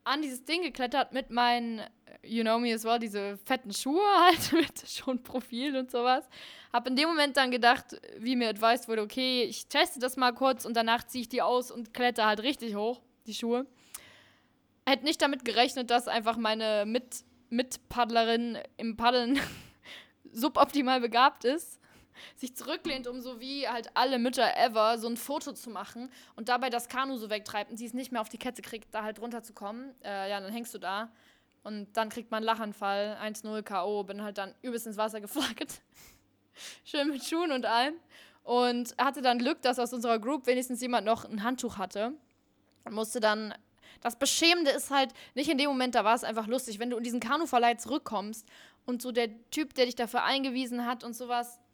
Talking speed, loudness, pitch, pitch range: 195 wpm, -30 LUFS, 245 Hz, 225-260 Hz